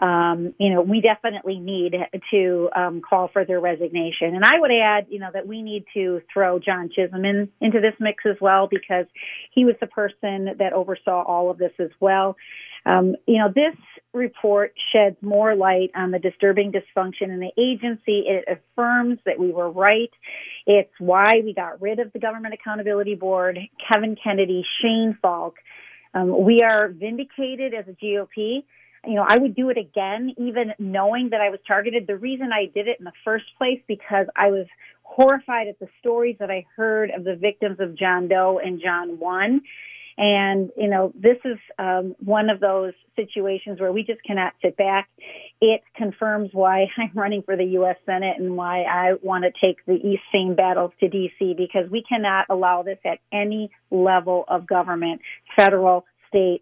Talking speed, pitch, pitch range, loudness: 185 wpm, 200 Hz, 185-220 Hz, -21 LUFS